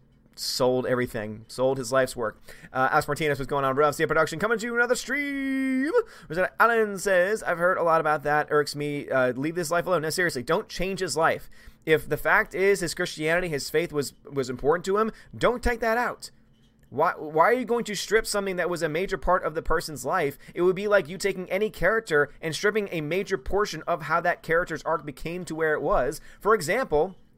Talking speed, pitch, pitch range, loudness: 225 wpm, 170 Hz, 150-195 Hz, -25 LUFS